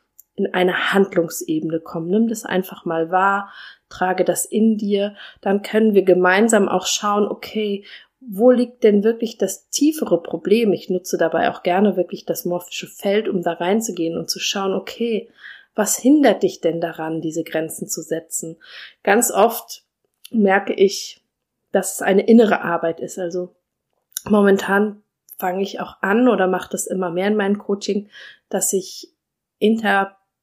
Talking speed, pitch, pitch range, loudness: 155 wpm, 195 Hz, 180-215 Hz, -19 LUFS